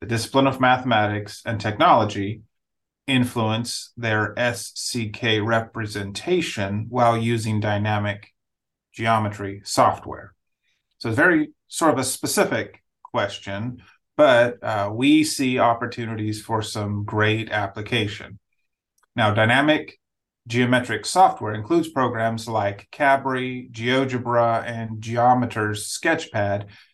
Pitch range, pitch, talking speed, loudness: 105-125 Hz, 115 Hz, 100 wpm, -22 LUFS